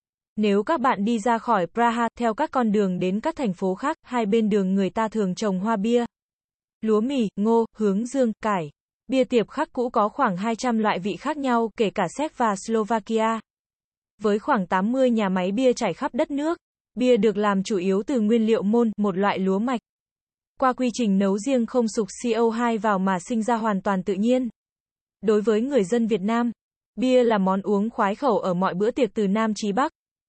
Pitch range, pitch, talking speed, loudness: 205-245 Hz, 225 Hz, 210 wpm, -23 LUFS